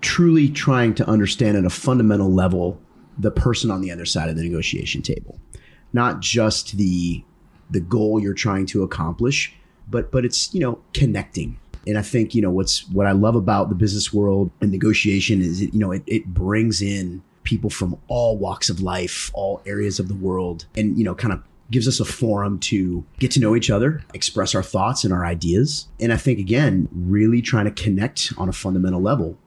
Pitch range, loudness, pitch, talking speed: 95-115 Hz, -20 LUFS, 100 Hz, 205 wpm